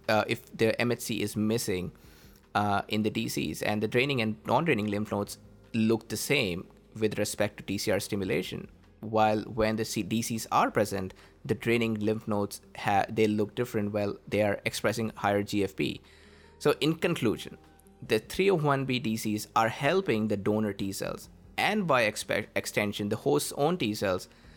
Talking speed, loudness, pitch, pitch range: 160 wpm, -29 LUFS, 110 Hz, 105-115 Hz